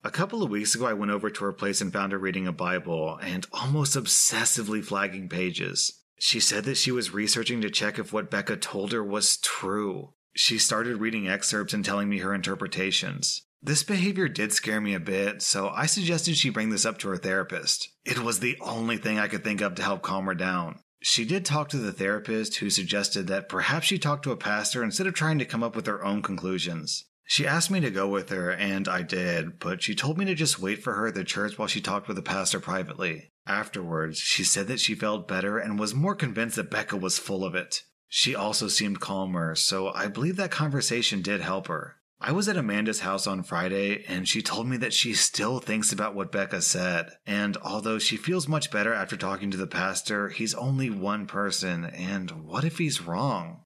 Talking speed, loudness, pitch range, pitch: 225 wpm, -27 LUFS, 95-130 Hz, 105 Hz